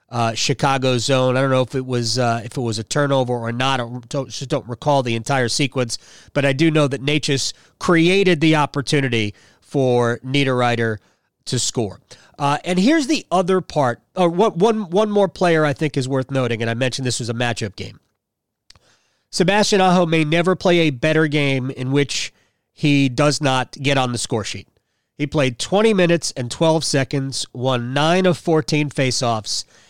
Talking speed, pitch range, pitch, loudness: 190 wpm, 120-160 Hz, 135 Hz, -19 LUFS